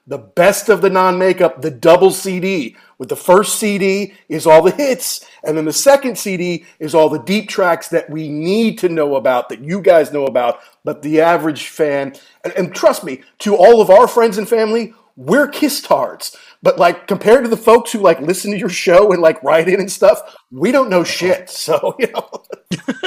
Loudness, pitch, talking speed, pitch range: -14 LUFS, 185 Hz, 210 wpm, 160-215 Hz